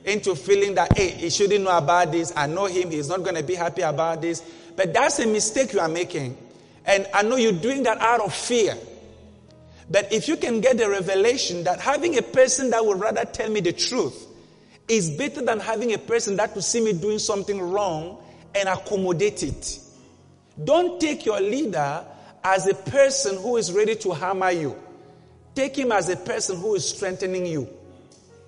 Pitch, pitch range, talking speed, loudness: 200 Hz, 180-230 Hz, 195 wpm, -23 LUFS